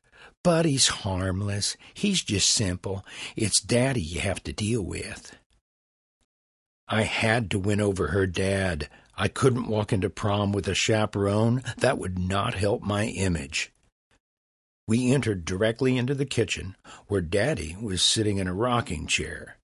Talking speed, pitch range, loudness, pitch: 145 wpm, 90-115 Hz, -26 LUFS, 100 Hz